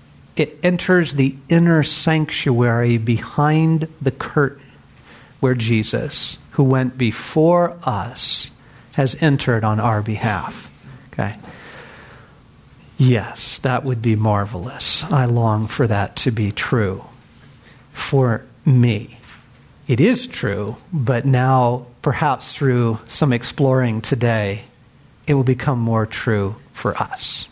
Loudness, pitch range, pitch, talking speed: -19 LUFS, 115-140 Hz, 125 Hz, 110 wpm